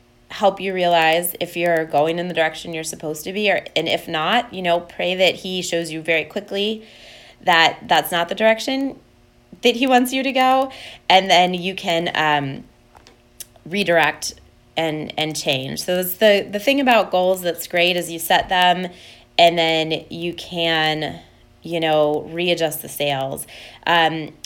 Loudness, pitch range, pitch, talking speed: -19 LUFS, 160-190 Hz, 170 Hz, 170 wpm